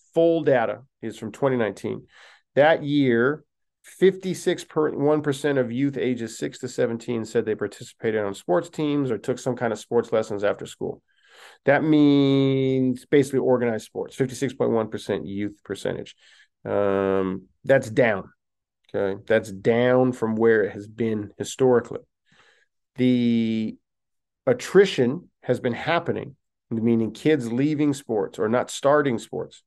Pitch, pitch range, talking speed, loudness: 125 Hz, 110-140 Hz, 125 wpm, -23 LUFS